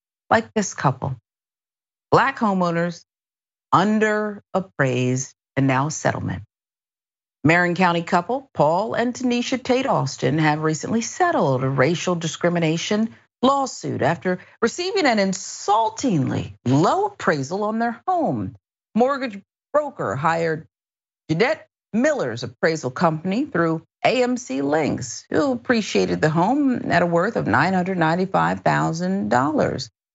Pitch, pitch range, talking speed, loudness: 180 Hz, 155-235 Hz, 105 wpm, -21 LUFS